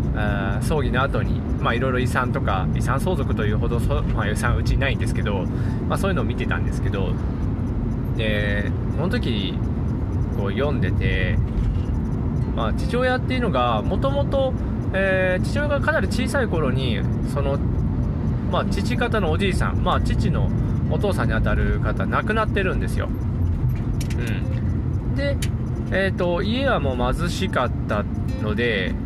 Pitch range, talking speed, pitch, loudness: 105-120 Hz, 295 characters per minute, 115 Hz, -22 LUFS